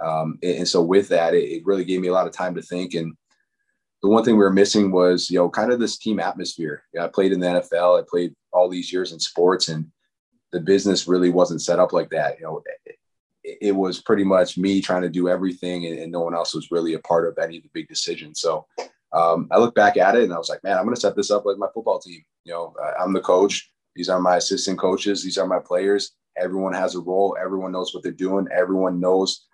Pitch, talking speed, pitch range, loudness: 90 Hz, 265 wpm, 90-100 Hz, -21 LUFS